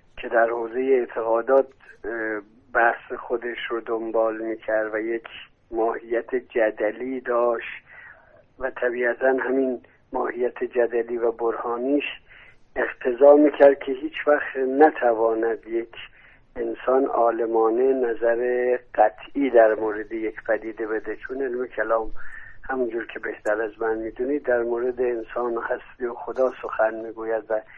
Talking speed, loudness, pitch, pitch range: 120 wpm, -23 LUFS, 115 Hz, 115-125 Hz